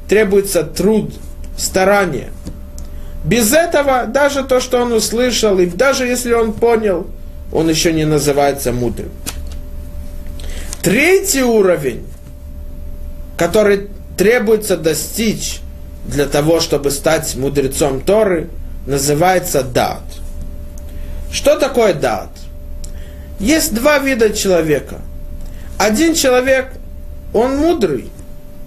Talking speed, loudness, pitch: 90 wpm, -14 LUFS, 150 Hz